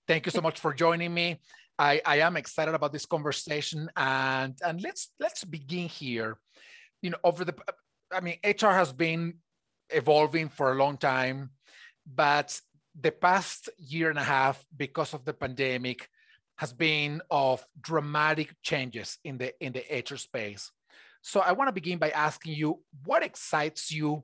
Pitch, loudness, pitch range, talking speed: 155 Hz, -29 LUFS, 140-170 Hz, 165 wpm